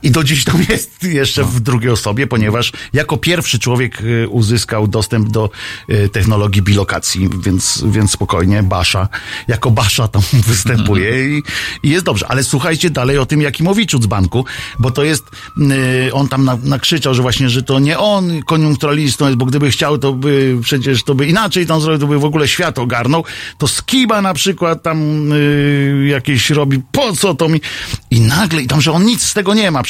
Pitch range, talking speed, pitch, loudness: 115-150 Hz, 185 wpm, 135 Hz, -13 LUFS